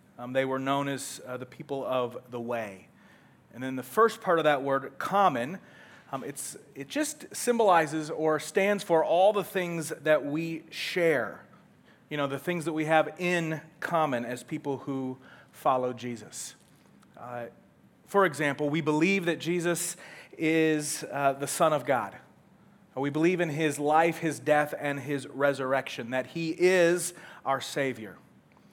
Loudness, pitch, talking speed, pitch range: -28 LUFS, 150 Hz, 160 wpm, 135-170 Hz